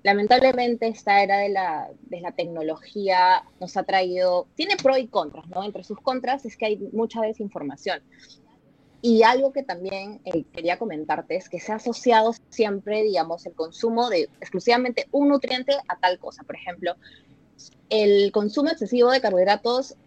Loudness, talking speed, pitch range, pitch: -23 LUFS, 160 wpm, 185-240 Hz, 210 Hz